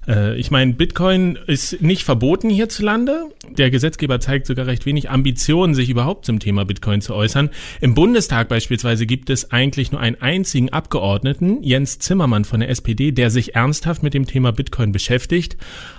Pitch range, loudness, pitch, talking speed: 120-155 Hz, -17 LUFS, 135 Hz, 165 wpm